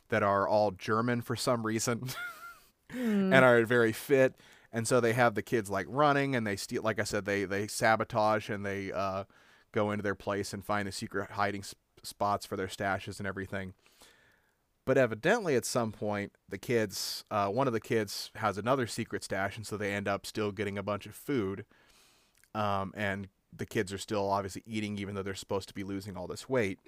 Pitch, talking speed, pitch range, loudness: 105 Hz, 205 wpm, 100-120 Hz, -31 LUFS